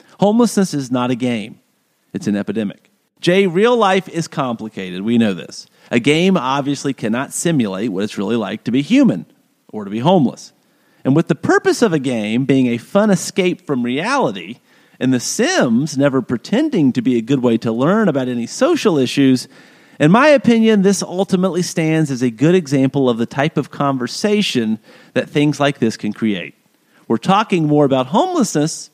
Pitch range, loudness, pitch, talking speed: 125-195 Hz, -16 LUFS, 145 Hz, 180 wpm